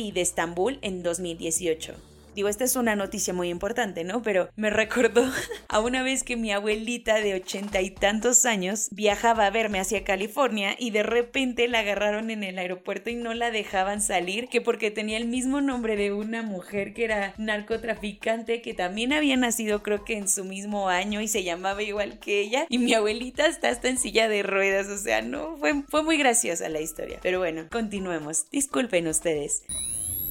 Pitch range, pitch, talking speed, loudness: 195-235 Hz, 210 Hz, 190 wpm, -26 LUFS